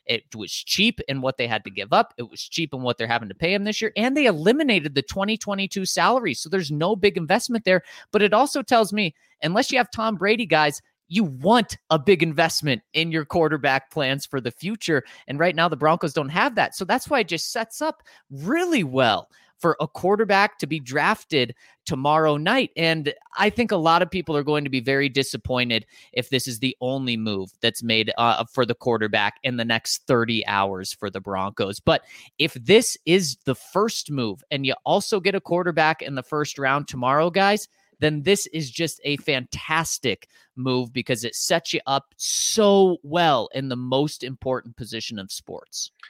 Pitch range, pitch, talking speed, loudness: 130-200 Hz, 155 Hz, 200 wpm, -22 LUFS